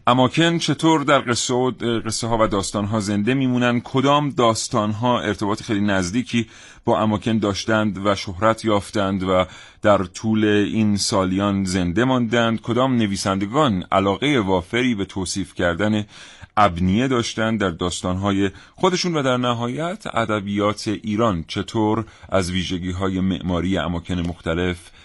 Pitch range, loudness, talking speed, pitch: 95-120 Hz, -20 LUFS, 130 wpm, 105 Hz